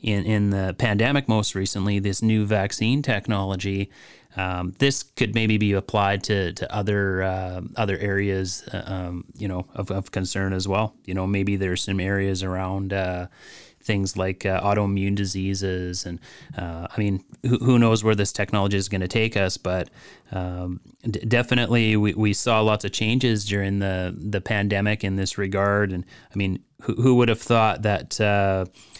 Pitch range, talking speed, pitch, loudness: 95-110 Hz, 180 wpm, 100 Hz, -23 LUFS